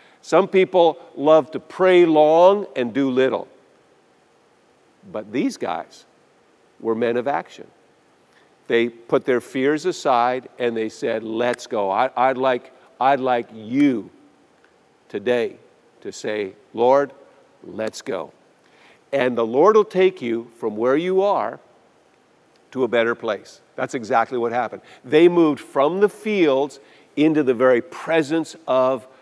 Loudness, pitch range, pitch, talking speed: -20 LUFS, 120-165 Hz, 130 Hz, 135 wpm